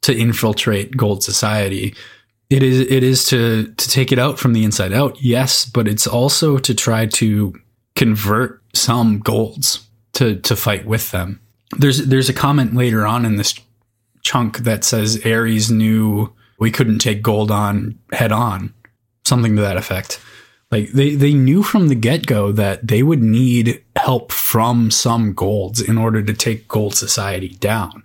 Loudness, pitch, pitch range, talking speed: -16 LUFS, 115 Hz, 105-125 Hz, 165 wpm